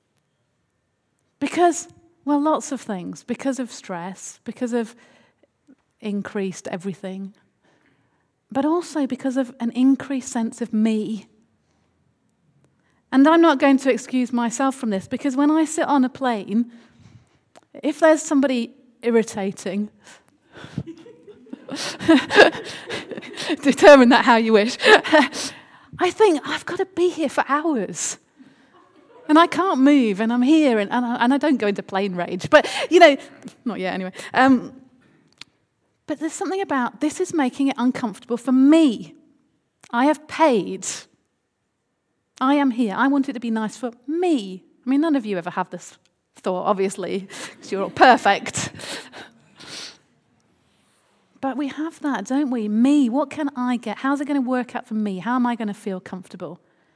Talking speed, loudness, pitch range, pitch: 150 wpm, -20 LUFS, 220-290 Hz, 255 Hz